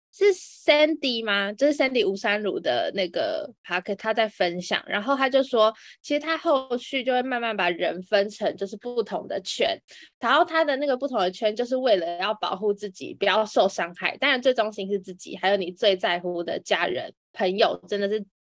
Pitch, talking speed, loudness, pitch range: 225 Hz, 320 characters per minute, -24 LUFS, 200-275 Hz